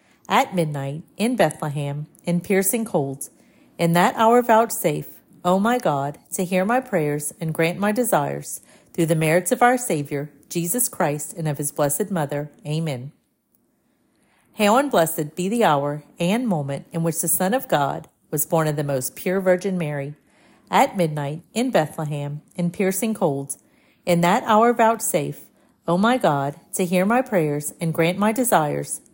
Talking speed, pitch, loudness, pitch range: 170 wpm, 175 Hz, -21 LUFS, 150-215 Hz